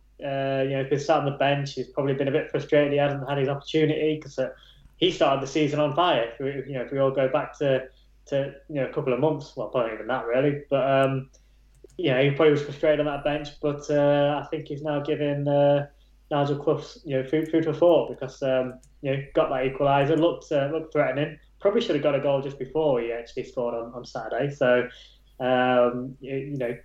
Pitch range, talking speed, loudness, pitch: 130-150 Hz, 245 wpm, -25 LUFS, 140 Hz